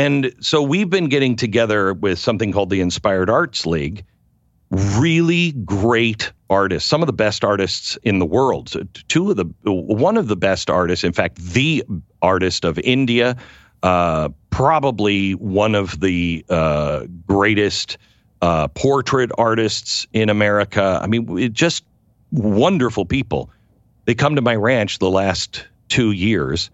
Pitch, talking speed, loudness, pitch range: 105 Hz, 145 wpm, -18 LUFS, 95-125 Hz